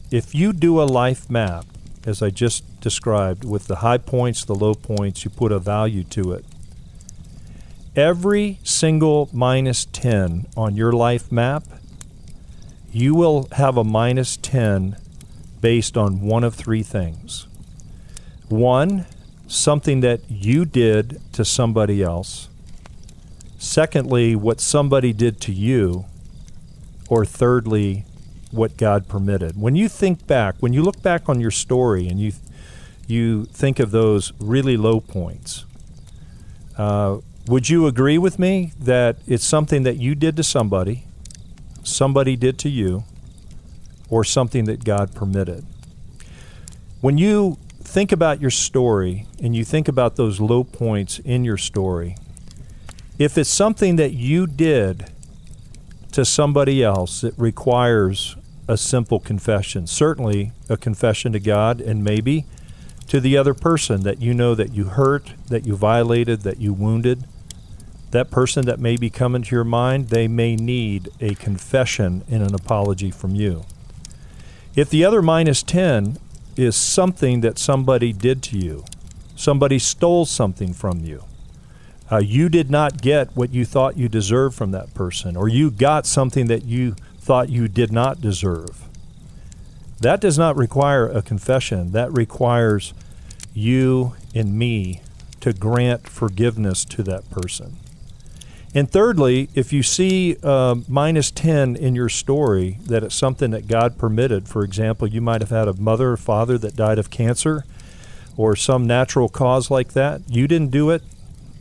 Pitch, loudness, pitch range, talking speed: 120 Hz, -19 LUFS, 105-135 Hz, 150 wpm